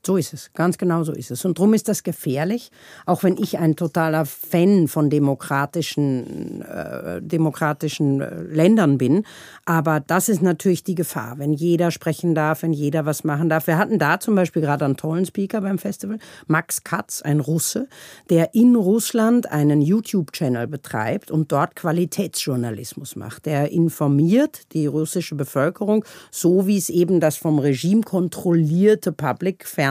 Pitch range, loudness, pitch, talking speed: 150-190 Hz, -20 LUFS, 165 Hz, 160 wpm